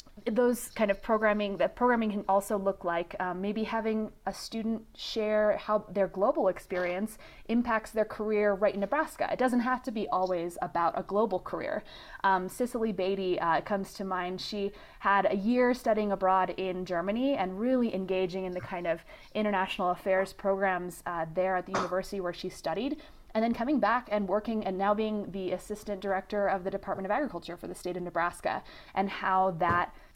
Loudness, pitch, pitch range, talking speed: -30 LUFS, 200 Hz, 185-220 Hz, 185 wpm